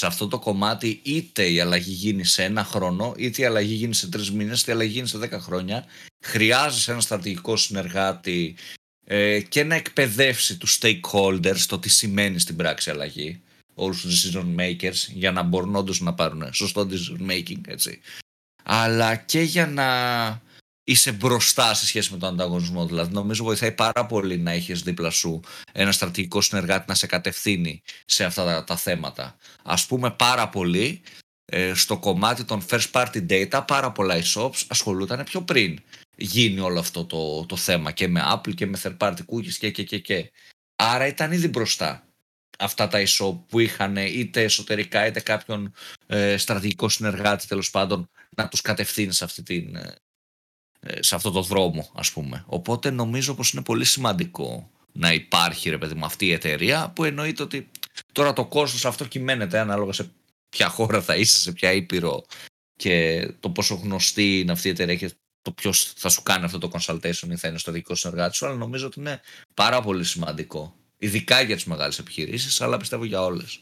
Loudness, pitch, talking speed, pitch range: -22 LUFS, 100 Hz, 180 wpm, 90-115 Hz